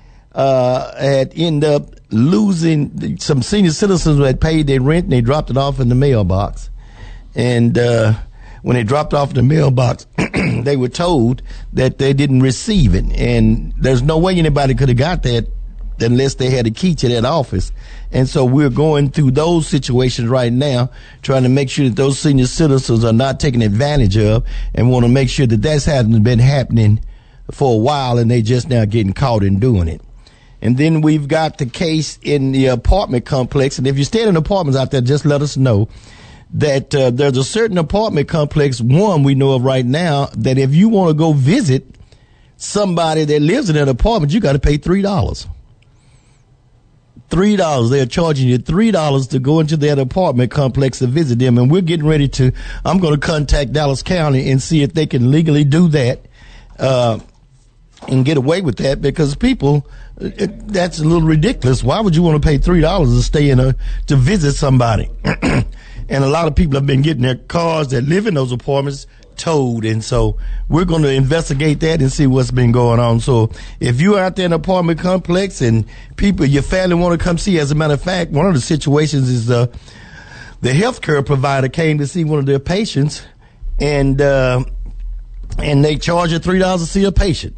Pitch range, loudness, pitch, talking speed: 125-155 Hz, -14 LUFS, 140 Hz, 205 wpm